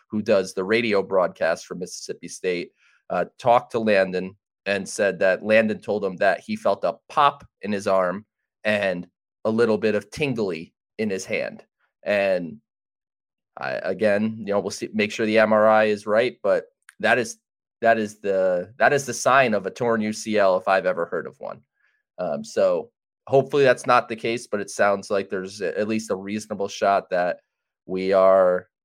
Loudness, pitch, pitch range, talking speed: -22 LUFS, 105 Hz, 100-110 Hz, 185 wpm